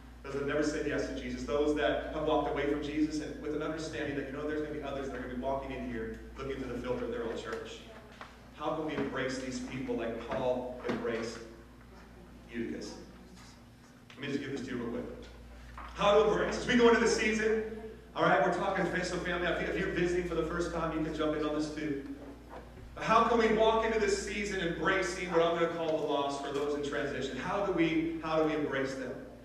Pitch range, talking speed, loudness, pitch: 130-170 Hz, 245 wpm, -32 LUFS, 150 Hz